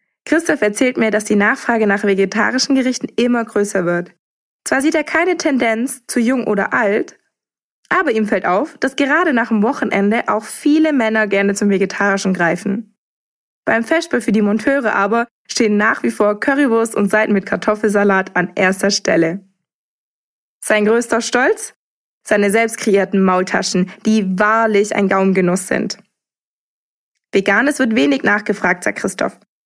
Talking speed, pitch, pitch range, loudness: 150 wpm, 215 Hz, 200-245 Hz, -16 LUFS